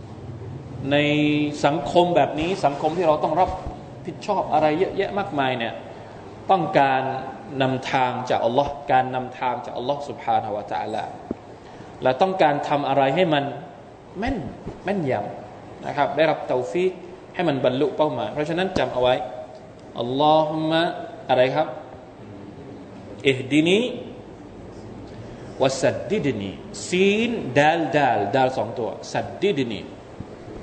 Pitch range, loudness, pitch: 125-155 Hz, -22 LUFS, 145 Hz